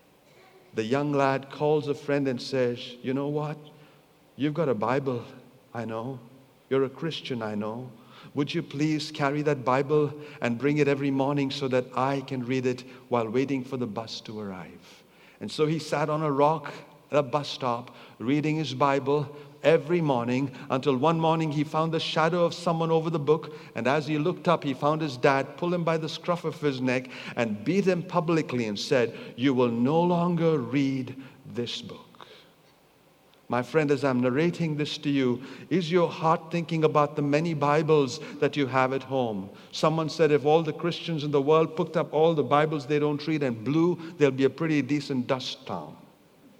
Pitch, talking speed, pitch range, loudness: 145 Hz, 195 wpm, 130-155 Hz, -27 LUFS